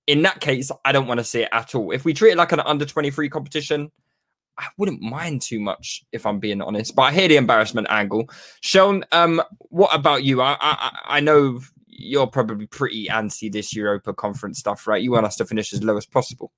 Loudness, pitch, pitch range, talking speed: -20 LUFS, 135 Hz, 110-150 Hz, 225 wpm